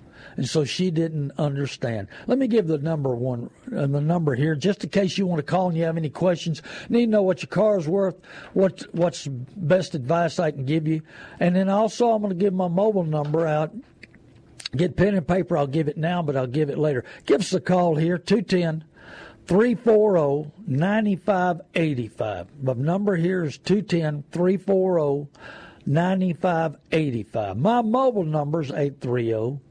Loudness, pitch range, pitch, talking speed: -23 LUFS, 150-190 Hz, 170 Hz, 165 wpm